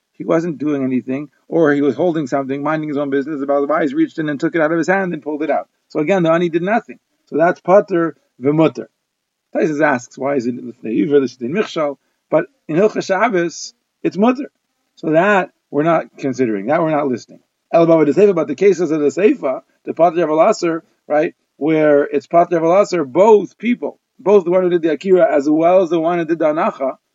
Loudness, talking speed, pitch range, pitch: -16 LUFS, 215 wpm, 145-190 Hz, 165 Hz